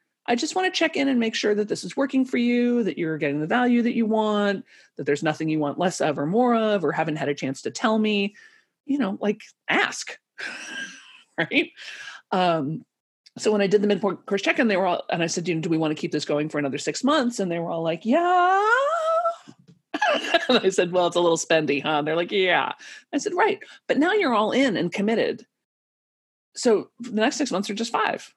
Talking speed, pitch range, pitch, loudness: 230 wpm, 170-275 Hz, 215 Hz, -23 LUFS